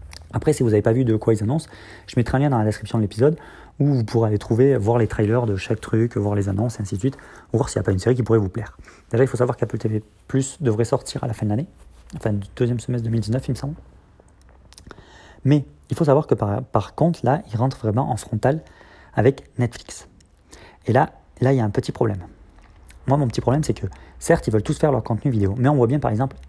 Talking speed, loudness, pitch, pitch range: 265 wpm, -21 LUFS, 115 Hz, 105-135 Hz